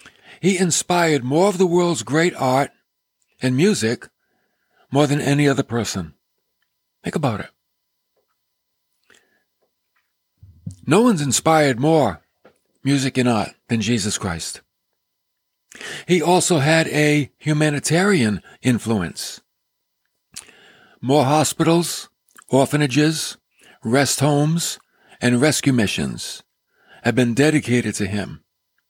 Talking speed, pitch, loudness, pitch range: 100 wpm, 140 Hz, -19 LUFS, 120-160 Hz